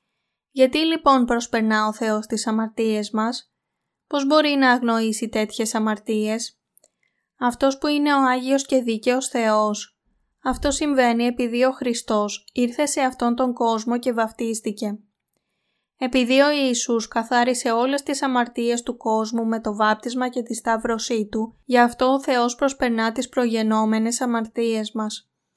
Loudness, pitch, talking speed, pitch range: -21 LUFS, 235 Hz, 140 wpm, 225-255 Hz